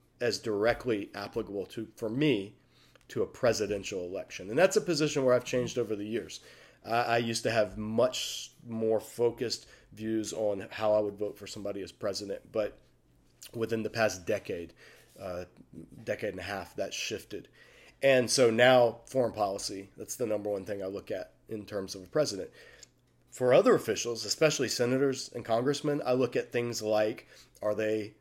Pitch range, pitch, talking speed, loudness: 105-125 Hz, 110 Hz, 170 wpm, -31 LUFS